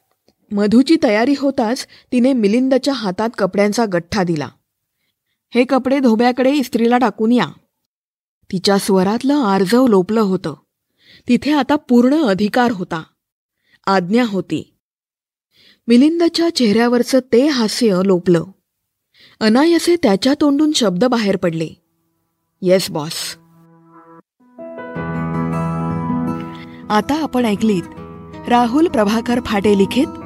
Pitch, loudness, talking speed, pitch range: 220 Hz, -16 LUFS, 95 wpm, 175-250 Hz